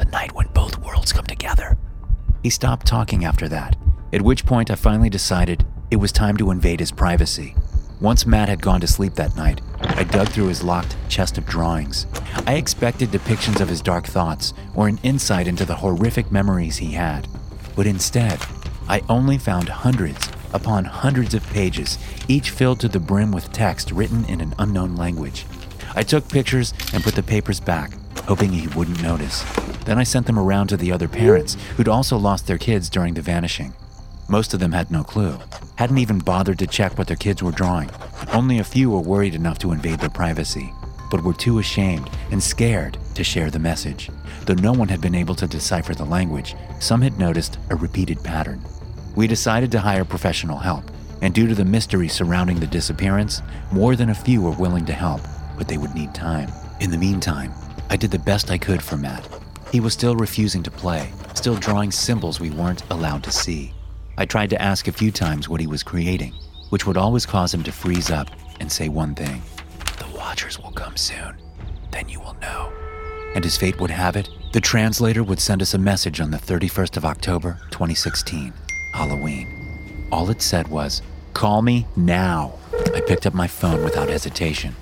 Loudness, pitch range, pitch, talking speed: -21 LUFS, 80-105 Hz, 90 Hz, 195 wpm